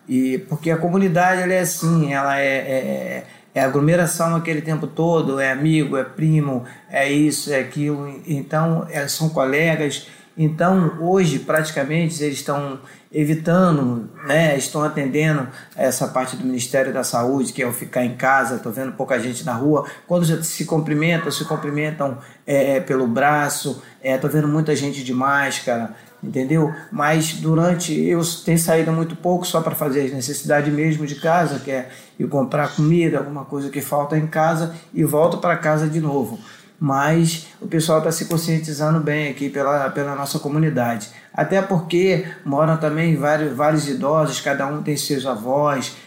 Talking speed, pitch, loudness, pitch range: 160 wpm, 150 Hz, -20 LUFS, 140-160 Hz